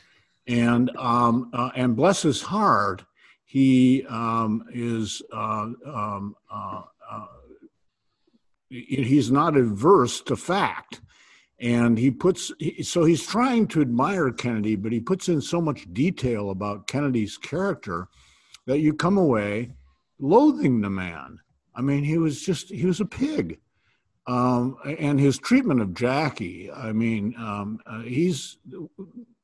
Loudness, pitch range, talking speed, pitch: -23 LUFS, 115-160 Hz, 135 wpm, 125 Hz